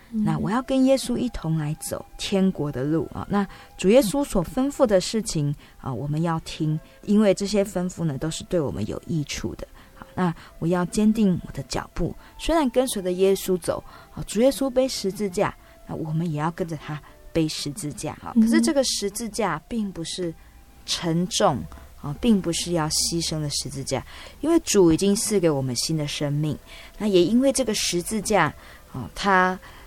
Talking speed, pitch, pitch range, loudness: 265 characters per minute, 175 Hz, 150-205 Hz, -24 LUFS